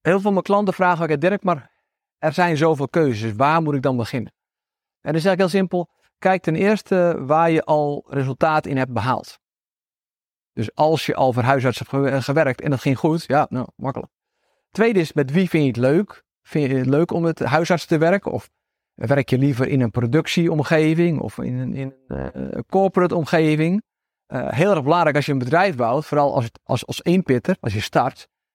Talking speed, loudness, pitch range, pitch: 205 wpm, -20 LUFS, 135-175 Hz, 155 Hz